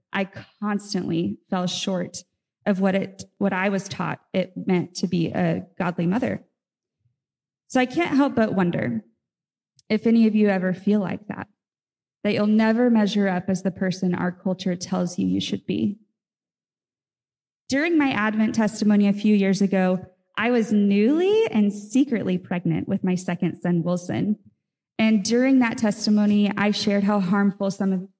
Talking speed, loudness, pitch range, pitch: 160 wpm, -23 LUFS, 180-215 Hz, 200 Hz